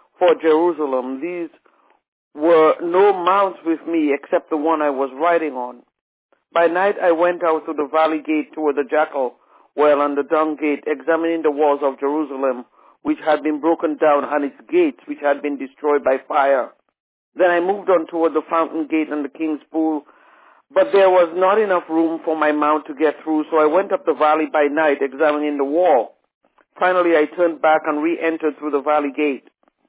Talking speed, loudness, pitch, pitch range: 195 wpm, -18 LUFS, 155 Hz, 150-165 Hz